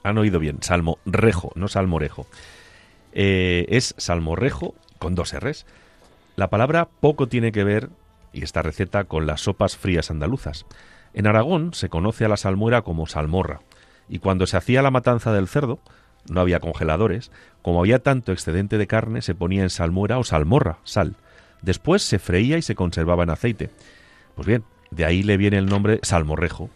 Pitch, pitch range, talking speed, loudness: 95 Hz, 85-110 Hz, 170 wpm, -21 LUFS